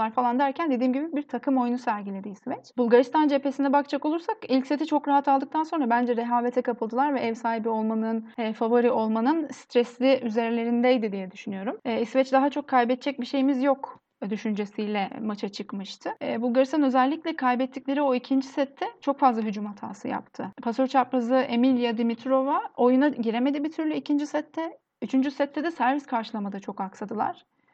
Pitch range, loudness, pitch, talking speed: 230-280 Hz, -26 LUFS, 255 Hz, 160 wpm